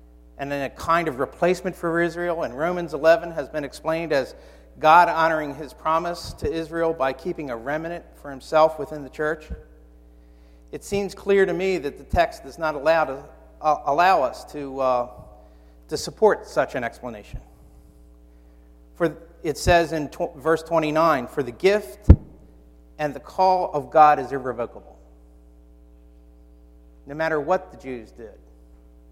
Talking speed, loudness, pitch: 155 wpm, -22 LUFS, 145 Hz